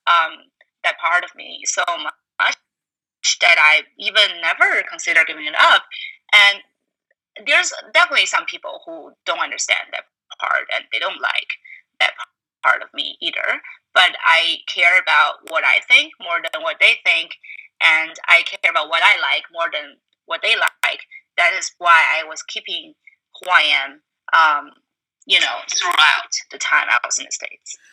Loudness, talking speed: -16 LUFS, 165 wpm